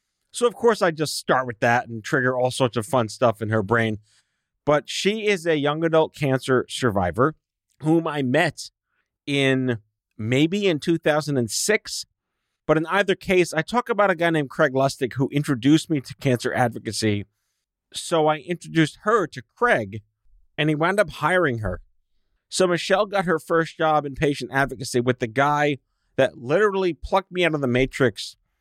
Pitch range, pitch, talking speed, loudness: 120-165 Hz, 145 Hz, 175 wpm, -22 LUFS